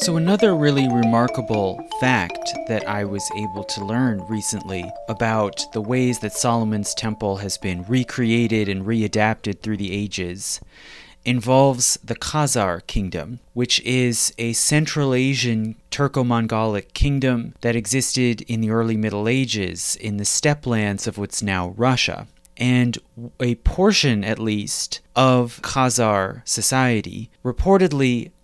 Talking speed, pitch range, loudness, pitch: 130 wpm, 105-125 Hz, -21 LUFS, 115 Hz